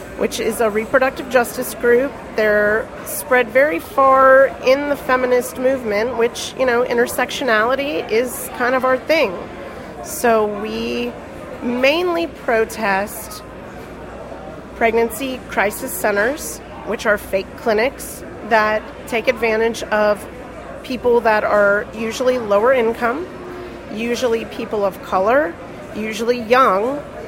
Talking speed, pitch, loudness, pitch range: 110 wpm, 240 Hz, -17 LUFS, 220-260 Hz